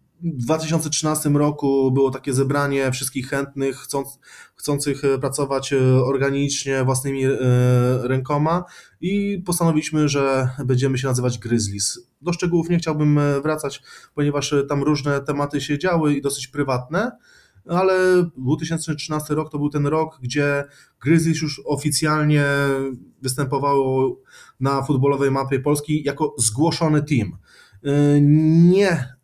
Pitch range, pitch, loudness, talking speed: 135-155 Hz, 145 Hz, -20 LUFS, 115 wpm